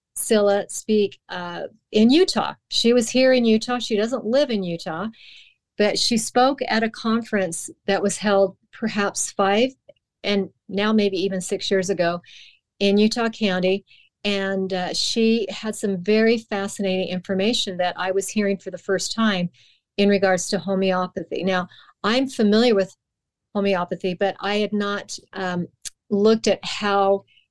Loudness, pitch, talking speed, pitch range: -21 LUFS, 200 Hz, 150 wpm, 190-220 Hz